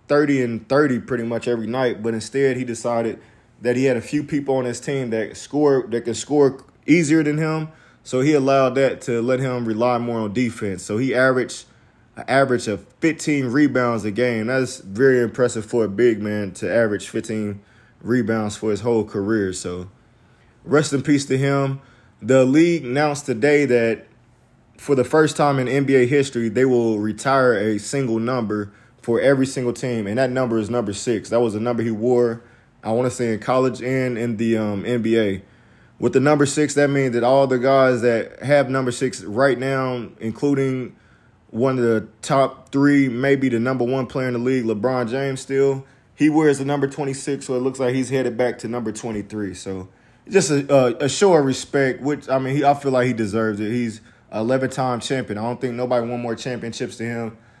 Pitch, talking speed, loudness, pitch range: 125 Hz, 200 wpm, -20 LUFS, 115-135 Hz